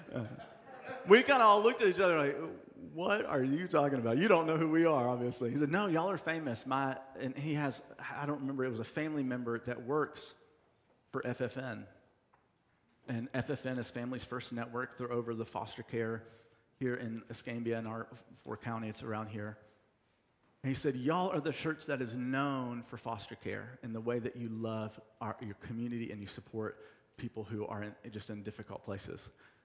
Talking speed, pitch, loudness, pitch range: 190 wpm, 125 Hz, -35 LUFS, 115-140 Hz